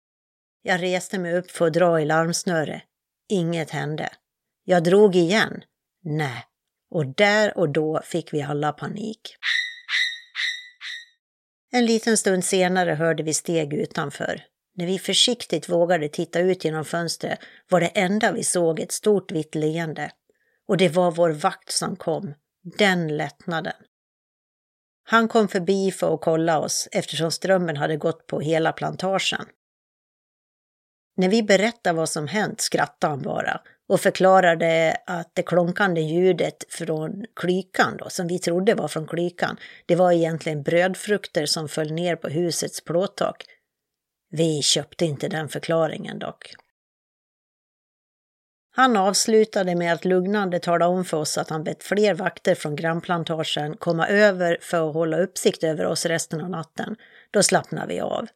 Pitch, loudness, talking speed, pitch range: 175 Hz, -22 LUFS, 145 wpm, 160-195 Hz